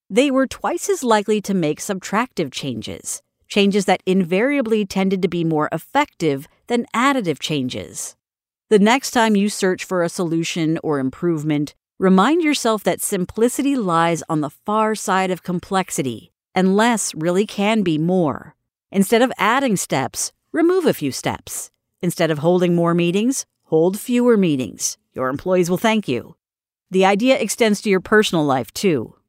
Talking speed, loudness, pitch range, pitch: 155 wpm, -19 LUFS, 165-220 Hz, 190 Hz